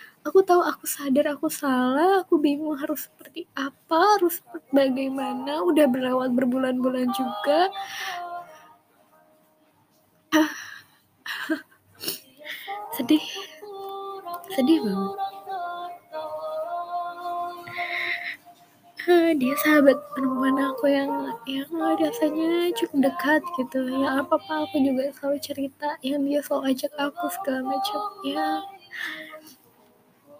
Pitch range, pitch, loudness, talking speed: 270-350 Hz, 305 Hz, -25 LUFS, 95 wpm